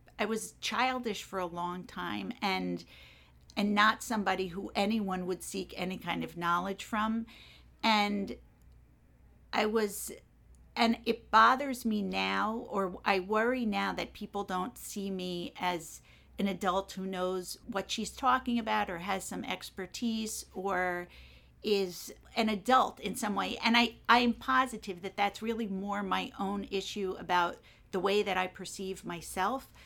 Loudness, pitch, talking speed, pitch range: -32 LUFS, 200 Hz, 155 wpm, 185-220 Hz